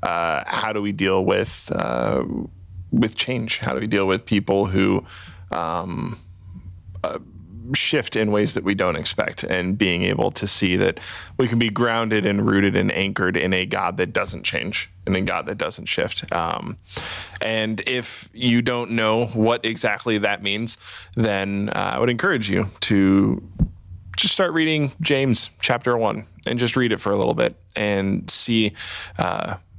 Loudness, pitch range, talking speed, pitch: -21 LUFS, 95-115 Hz, 170 wpm, 100 Hz